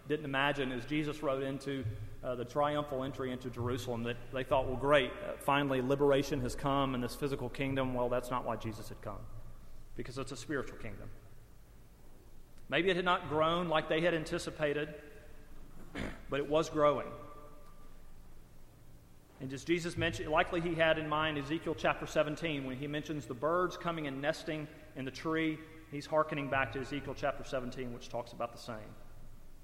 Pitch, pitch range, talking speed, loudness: 140 Hz, 120-155 Hz, 175 wpm, -35 LUFS